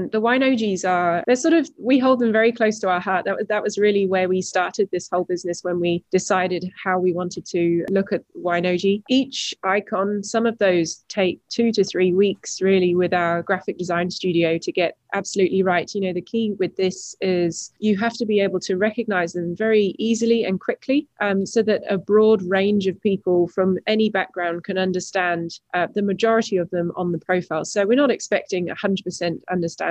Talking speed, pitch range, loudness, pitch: 205 wpm, 180-210 Hz, -21 LUFS, 190 Hz